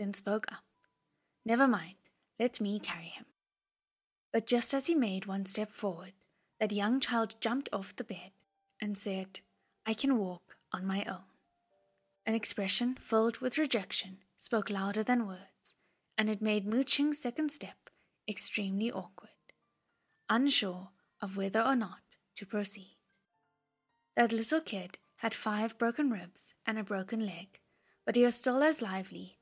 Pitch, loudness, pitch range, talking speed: 215 Hz, -27 LUFS, 195-240 Hz, 150 wpm